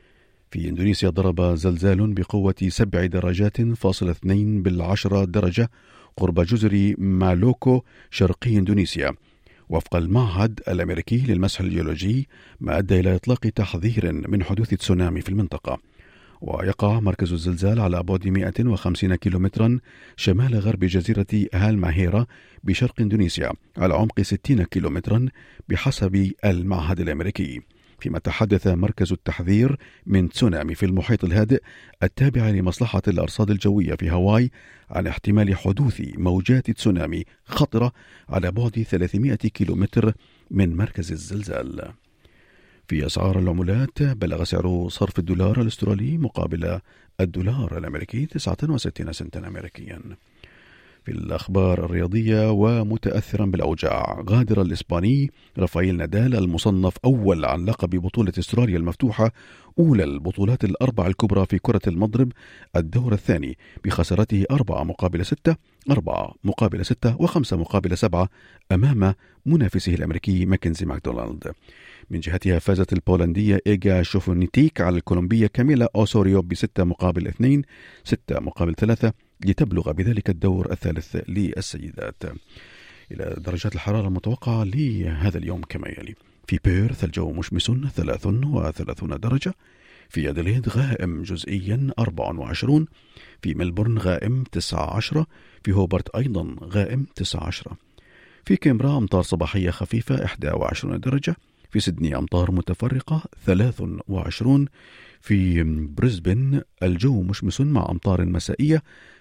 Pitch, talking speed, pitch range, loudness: 100 Hz, 110 wpm, 90-115 Hz, -22 LUFS